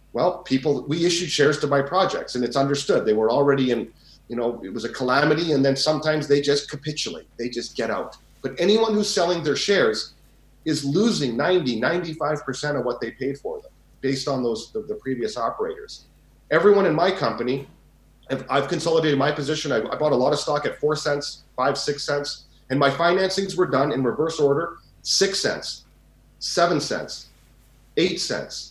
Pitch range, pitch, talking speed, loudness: 135-175 Hz, 145 Hz, 190 wpm, -23 LUFS